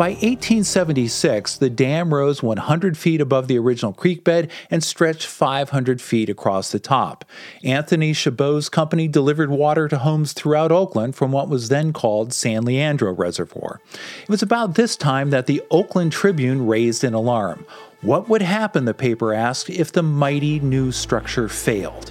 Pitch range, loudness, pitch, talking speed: 125-165 Hz, -19 LUFS, 145 Hz, 165 wpm